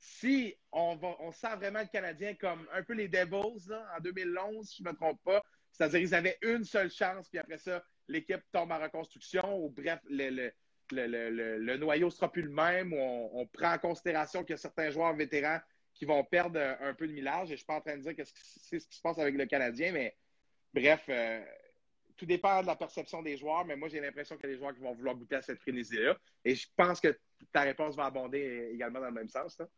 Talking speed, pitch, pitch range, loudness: 250 wpm, 160 Hz, 140-185 Hz, -35 LUFS